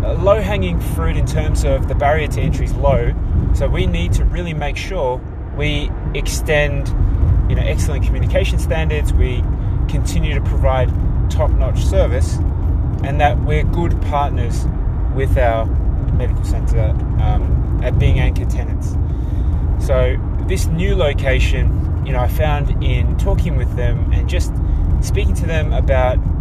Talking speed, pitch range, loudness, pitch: 150 wpm, 80-100 Hz, -18 LUFS, 90 Hz